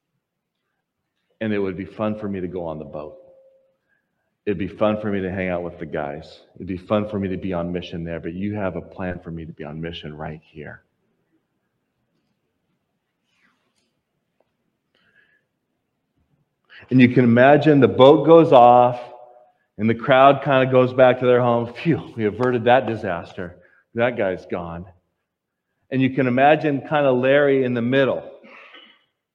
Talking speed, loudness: 170 wpm, -18 LUFS